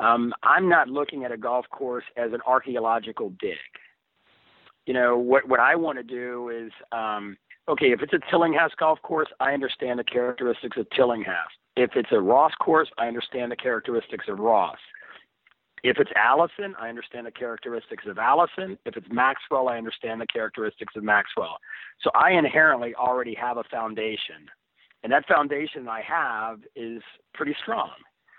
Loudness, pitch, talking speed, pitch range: -24 LUFS, 125 Hz, 165 wpm, 115-140 Hz